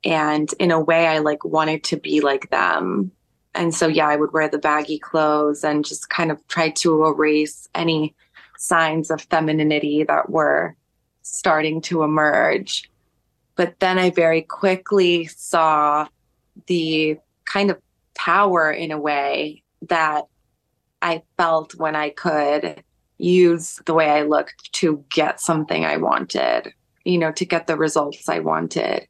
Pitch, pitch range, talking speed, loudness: 155 Hz, 150-165 Hz, 150 wpm, -20 LUFS